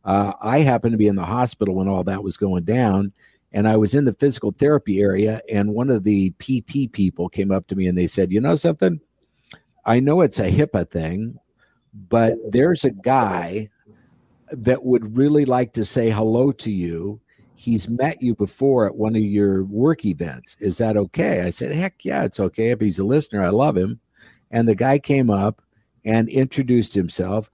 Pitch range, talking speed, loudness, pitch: 100-125 Hz, 200 wpm, -20 LUFS, 110 Hz